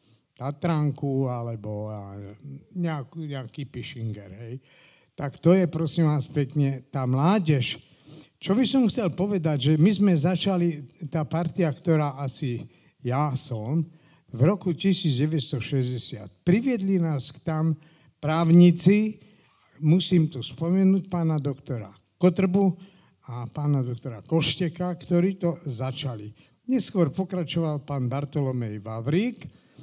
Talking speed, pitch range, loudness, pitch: 110 wpm, 130-175 Hz, -25 LUFS, 155 Hz